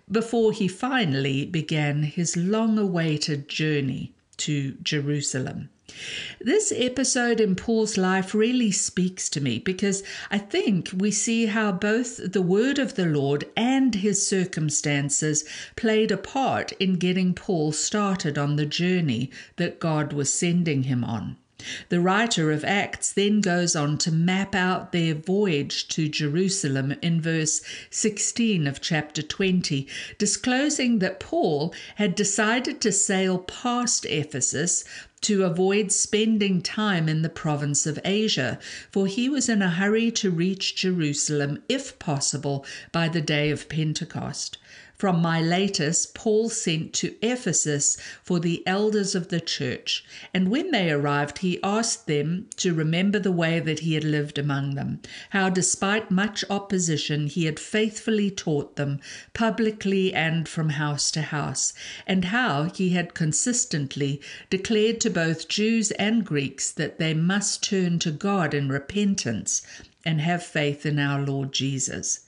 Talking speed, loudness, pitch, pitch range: 145 wpm, -24 LUFS, 180 Hz, 150-210 Hz